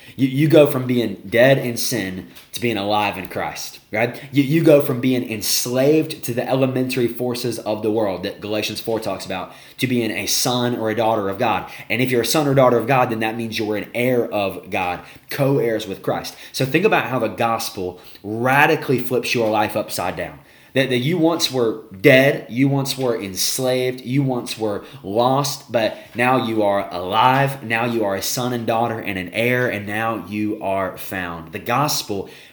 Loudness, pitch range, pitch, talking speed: -19 LUFS, 110-130 Hz, 120 Hz, 200 wpm